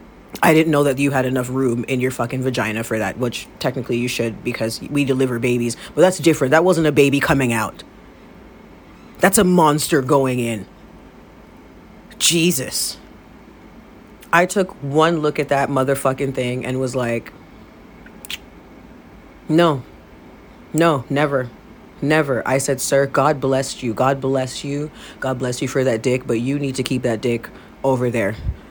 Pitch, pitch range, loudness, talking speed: 135 Hz, 125-145 Hz, -19 LUFS, 160 wpm